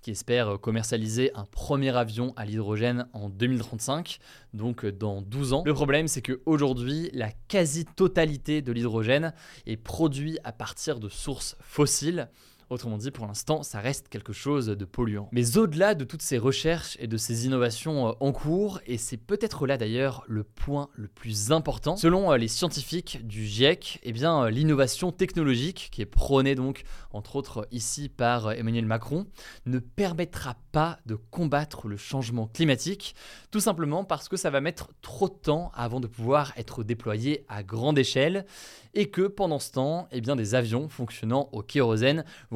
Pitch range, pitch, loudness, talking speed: 115-155 Hz, 135 Hz, -28 LUFS, 170 wpm